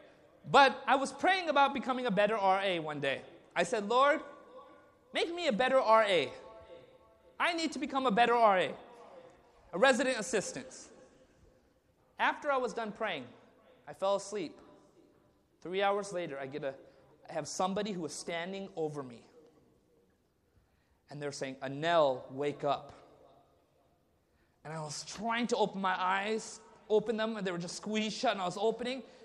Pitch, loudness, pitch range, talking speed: 210 Hz, -32 LUFS, 160-250 Hz, 160 wpm